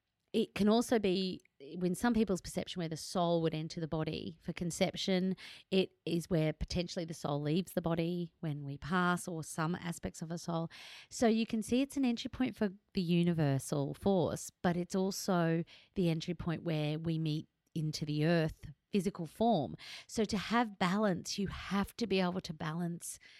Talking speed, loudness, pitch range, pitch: 185 wpm, -35 LUFS, 160-195 Hz, 175 Hz